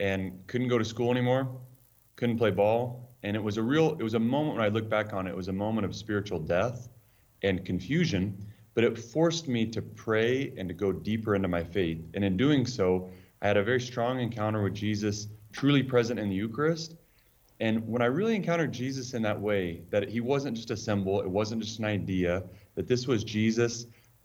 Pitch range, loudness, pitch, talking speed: 100-125 Hz, -29 LUFS, 110 Hz, 215 wpm